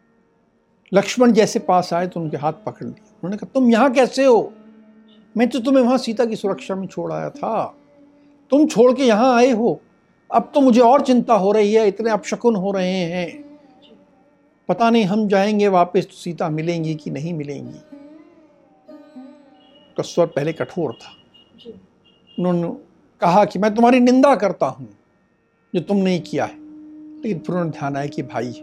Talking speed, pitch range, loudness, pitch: 165 wpm, 180-260 Hz, -18 LUFS, 215 Hz